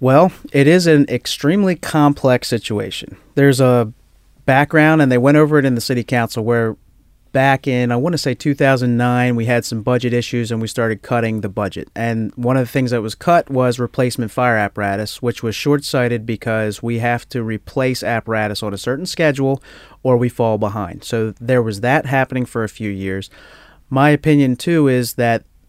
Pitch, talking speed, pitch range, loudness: 125 Hz, 190 wpm, 115-135 Hz, -17 LUFS